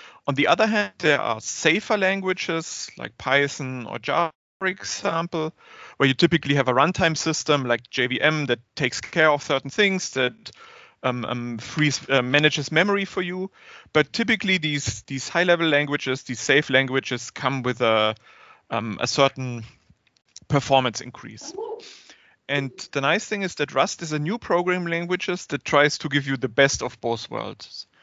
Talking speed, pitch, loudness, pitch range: 165 wpm, 145 Hz, -23 LUFS, 130-175 Hz